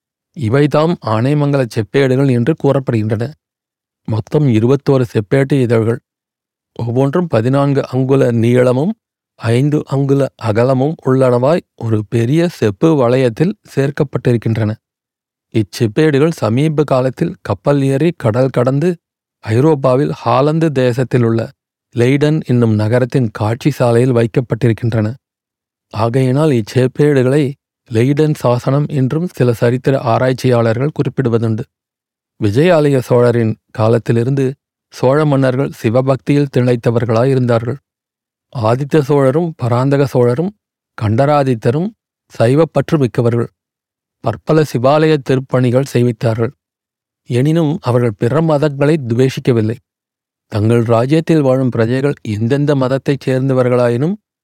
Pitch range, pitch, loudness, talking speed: 120-145 Hz, 130 Hz, -14 LUFS, 85 wpm